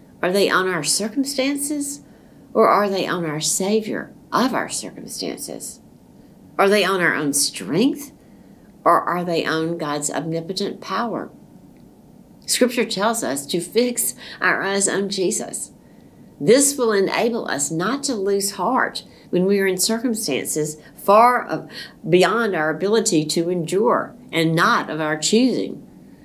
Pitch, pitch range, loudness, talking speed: 195 Hz, 165-230 Hz, -20 LUFS, 140 wpm